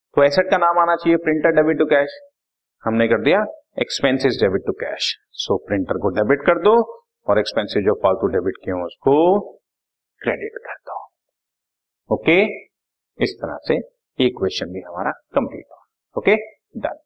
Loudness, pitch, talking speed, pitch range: -19 LUFS, 170 Hz, 170 wpm, 145-220 Hz